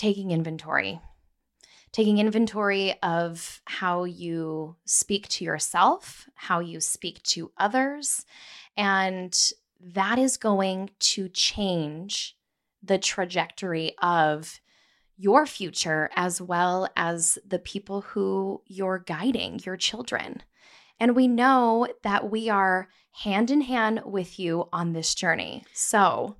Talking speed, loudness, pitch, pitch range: 115 wpm, -25 LUFS, 195 Hz, 175-215 Hz